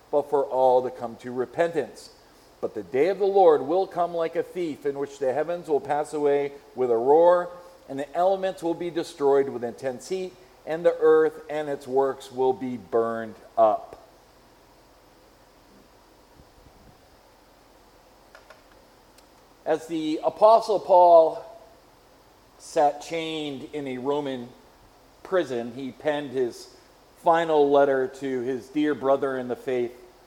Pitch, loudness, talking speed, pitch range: 150 Hz, -24 LUFS, 135 wpm, 135-175 Hz